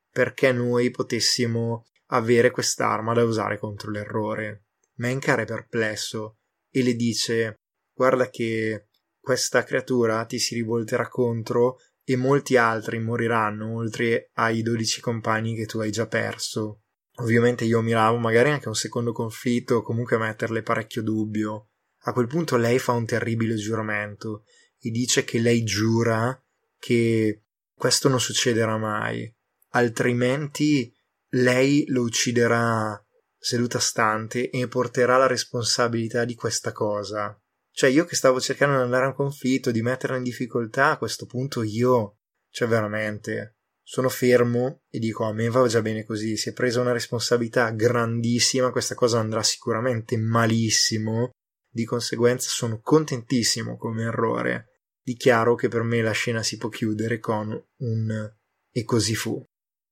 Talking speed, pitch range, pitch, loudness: 145 wpm, 110-125 Hz, 115 Hz, -23 LUFS